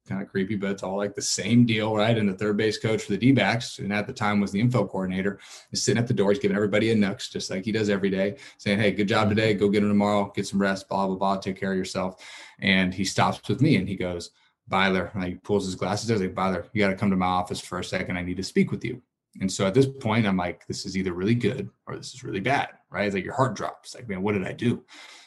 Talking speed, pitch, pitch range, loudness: 295 wpm, 100 Hz, 95-105 Hz, -25 LUFS